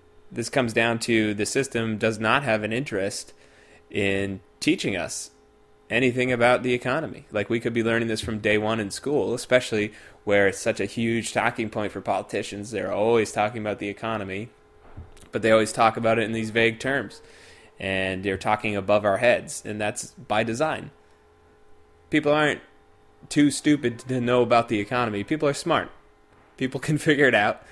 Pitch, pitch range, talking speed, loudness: 110 Hz, 105-125 Hz, 180 wpm, -24 LUFS